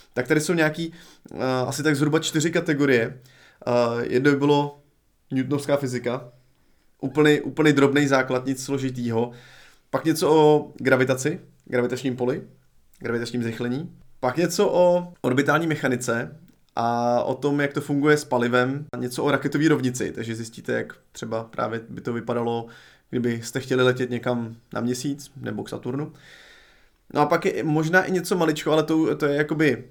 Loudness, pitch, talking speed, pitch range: -23 LUFS, 135 Hz, 150 wpm, 125-150 Hz